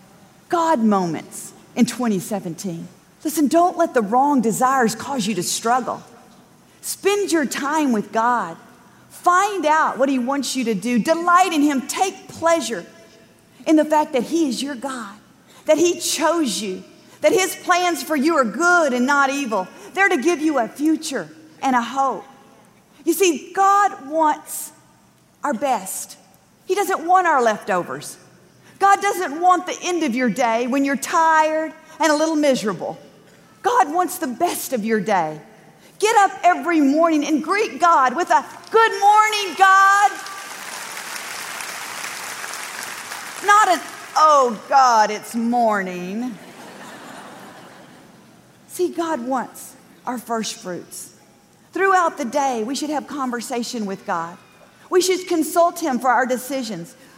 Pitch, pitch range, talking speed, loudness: 285 Hz, 235-345 Hz, 145 wpm, -19 LUFS